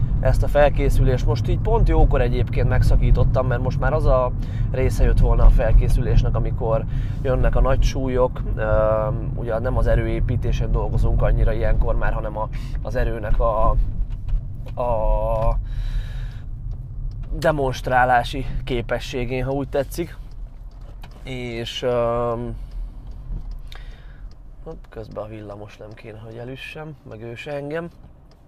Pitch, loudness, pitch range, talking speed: 120 Hz, -22 LUFS, 115-130 Hz, 120 wpm